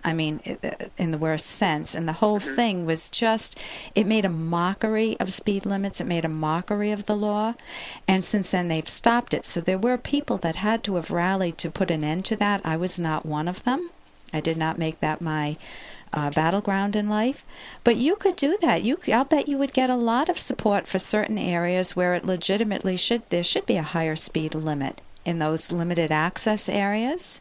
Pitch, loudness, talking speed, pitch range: 190 Hz, -24 LUFS, 210 wpm, 165-220 Hz